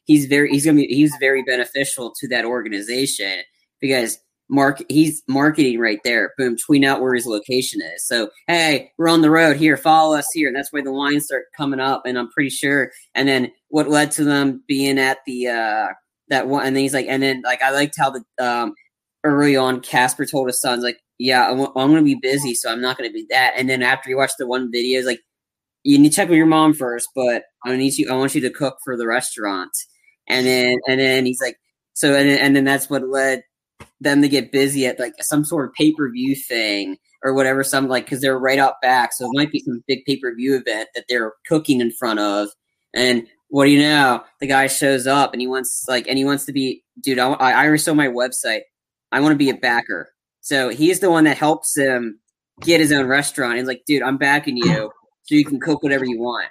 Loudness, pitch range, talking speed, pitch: -18 LUFS, 125-145 Hz, 235 wpm, 135 Hz